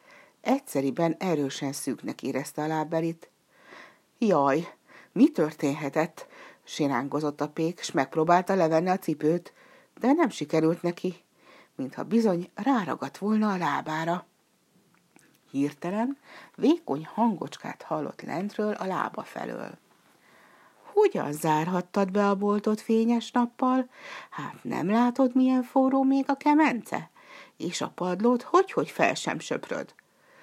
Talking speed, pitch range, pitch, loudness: 110 wpm, 160-260 Hz, 200 Hz, -27 LUFS